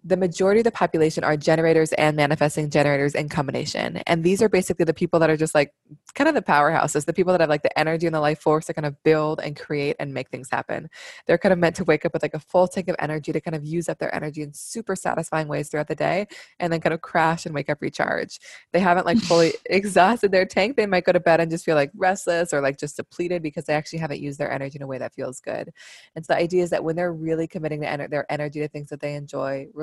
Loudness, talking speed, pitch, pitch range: -22 LUFS, 270 wpm, 160 Hz, 150-175 Hz